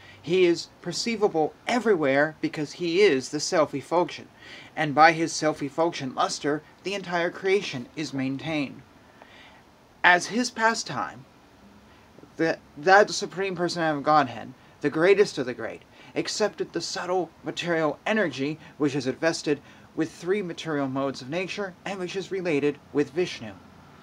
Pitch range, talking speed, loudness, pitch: 145-185 Hz, 135 wpm, -25 LUFS, 160 Hz